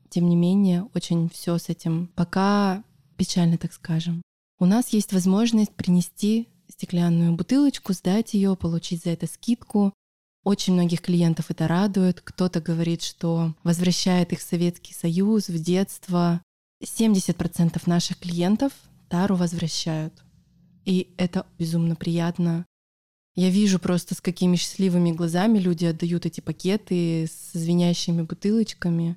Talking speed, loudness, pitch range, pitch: 130 wpm, -23 LUFS, 170-190 Hz, 175 Hz